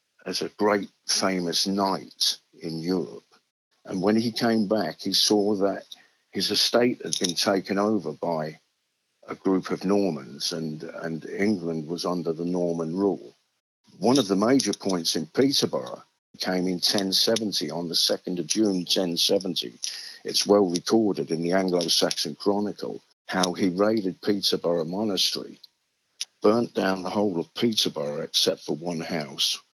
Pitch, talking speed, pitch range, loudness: 95 Hz, 145 wpm, 85-100 Hz, -25 LUFS